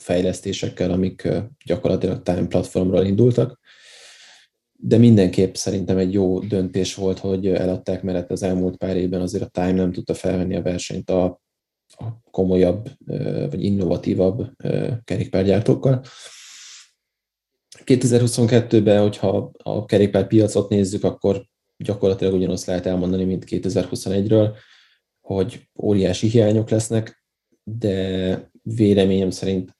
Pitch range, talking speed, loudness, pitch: 95-110 Hz, 105 wpm, -20 LUFS, 95 Hz